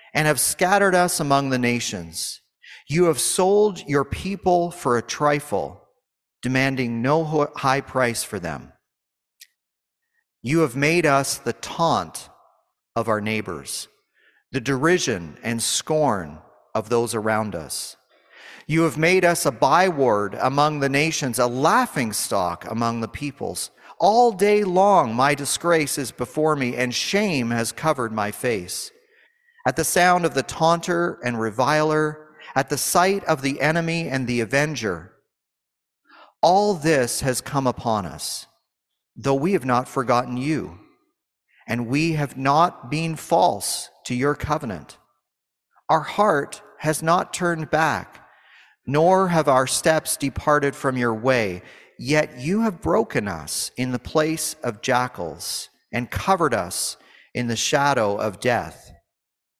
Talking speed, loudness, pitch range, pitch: 135 wpm, -21 LUFS, 120-165 Hz, 140 Hz